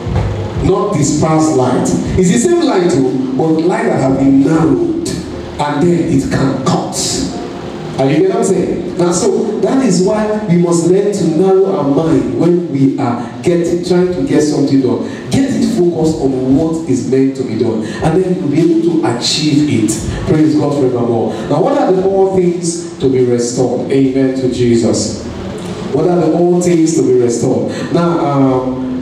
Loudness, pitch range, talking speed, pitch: -13 LUFS, 130-175 Hz, 190 wpm, 155 Hz